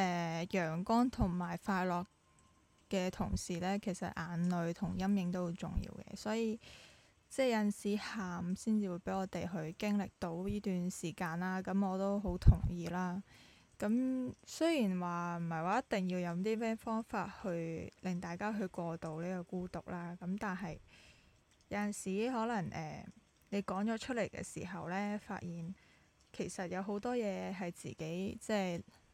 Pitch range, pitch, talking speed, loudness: 175-205 Hz, 190 Hz, 245 characters per minute, -38 LUFS